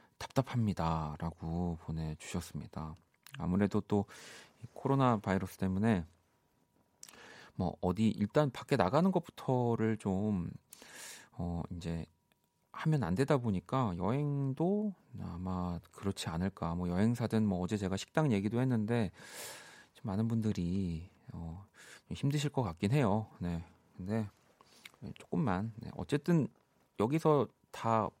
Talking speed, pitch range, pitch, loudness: 240 characters per minute, 90-125 Hz, 105 Hz, -35 LUFS